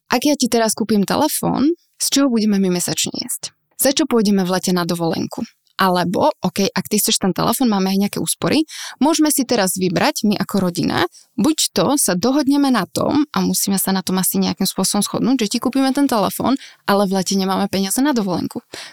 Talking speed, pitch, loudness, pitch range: 205 wpm, 210 Hz, -17 LUFS, 190-265 Hz